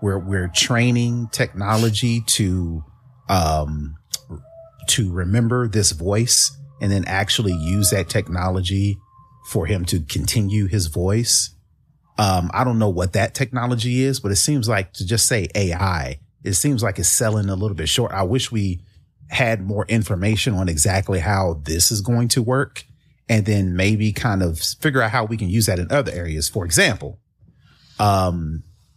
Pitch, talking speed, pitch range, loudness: 105 Hz, 165 wpm, 95-120 Hz, -19 LUFS